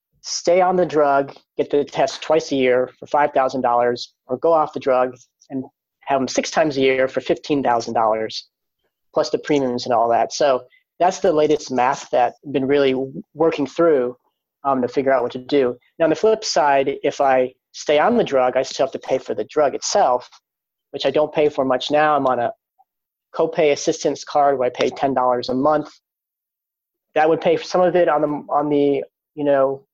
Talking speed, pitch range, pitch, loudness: 205 wpm, 130-155 Hz, 140 Hz, -19 LUFS